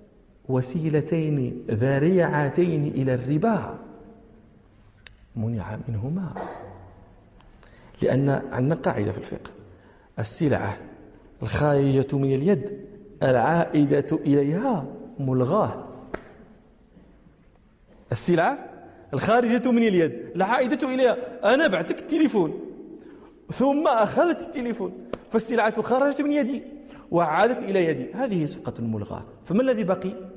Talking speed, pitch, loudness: 85 wpm, 170 Hz, -24 LUFS